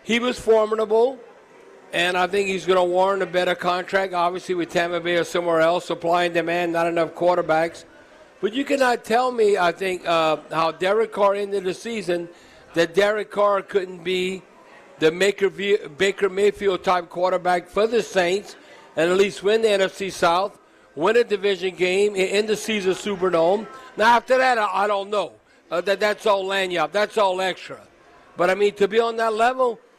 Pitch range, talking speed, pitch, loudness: 180-210 Hz, 180 wpm, 195 Hz, -21 LUFS